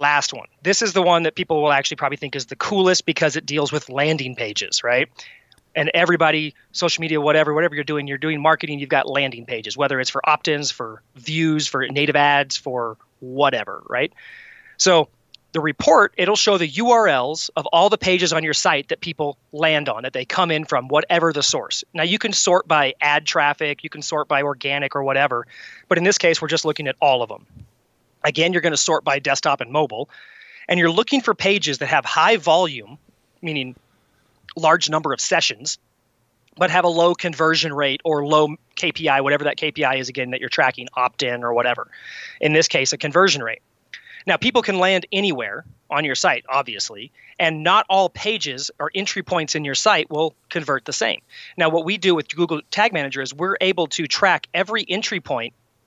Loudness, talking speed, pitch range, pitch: -19 LUFS, 205 wpm, 140-180 Hz, 155 Hz